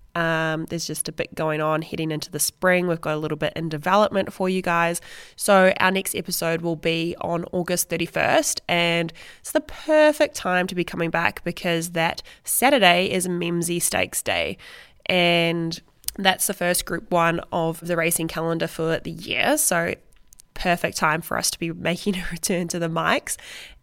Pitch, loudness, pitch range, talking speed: 170 Hz, -22 LUFS, 165-180 Hz, 180 wpm